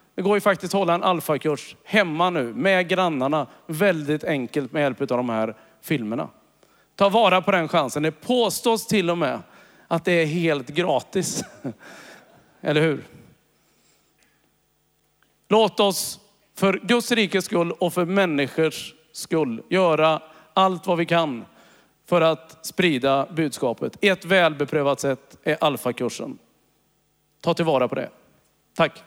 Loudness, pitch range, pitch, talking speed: -22 LUFS, 155-195 Hz, 170 Hz, 135 wpm